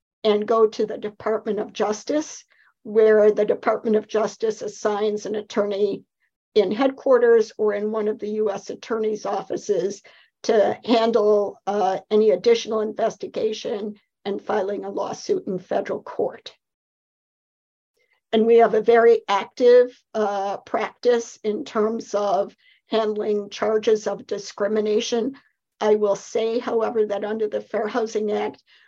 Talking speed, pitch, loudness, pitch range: 130 wpm, 215 Hz, -22 LUFS, 210-235 Hz